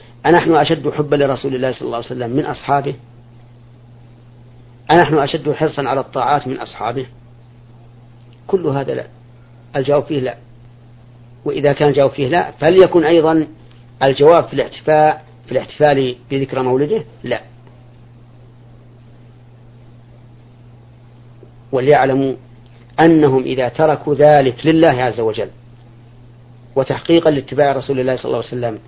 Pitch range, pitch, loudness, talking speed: 120-145 Hz, 125 Hz, -15 LUFS, 115 wpm